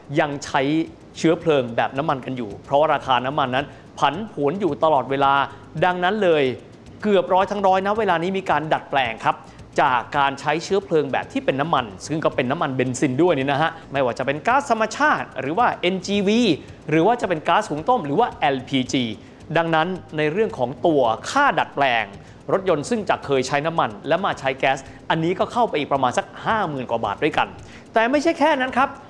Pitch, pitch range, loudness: 165 Hz, 140-210 Hz, -21 LUFS